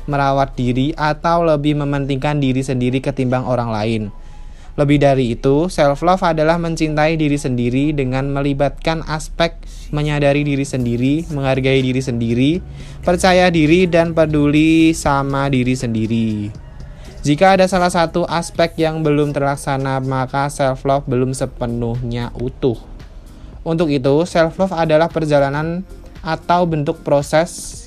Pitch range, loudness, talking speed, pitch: 130-160 Hz, -16 LUFS, 120 wpm, 145 Hz